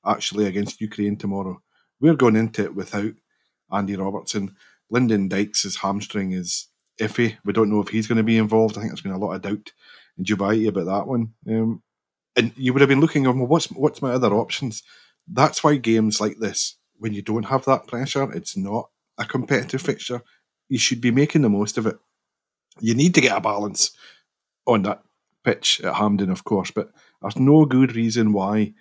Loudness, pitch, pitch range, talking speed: -21 LUFS, 110 Hz, 105-125 Hz, 195 wpm